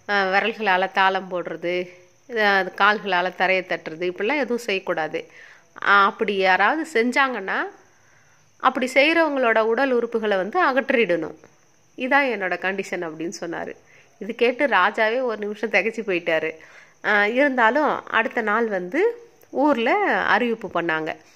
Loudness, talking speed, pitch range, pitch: -21 LUFS, 105 wpm, 185-260 Hz, 210 Hz